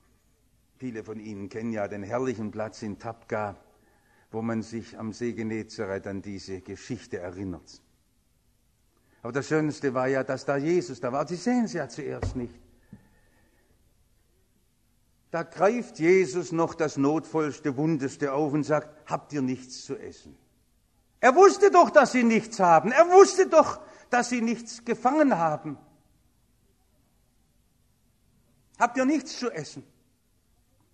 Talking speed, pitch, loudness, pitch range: 140 wpm, 130 Hz, -25 LUFS, 115-175 Hz